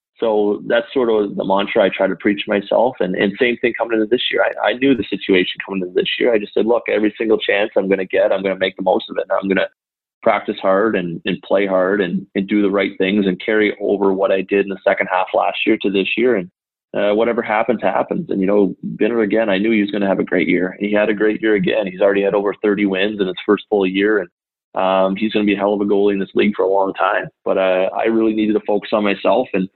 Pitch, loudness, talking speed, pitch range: 100 Hz, -17 LUFS, 290 wpm, 95-105 Hz